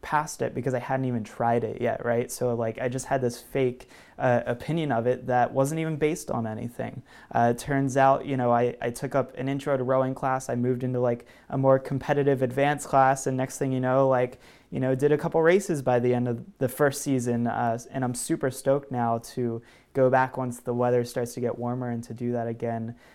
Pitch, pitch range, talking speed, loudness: 130 Hz, 120-135 Hz, 235 wpm, -26 LUFS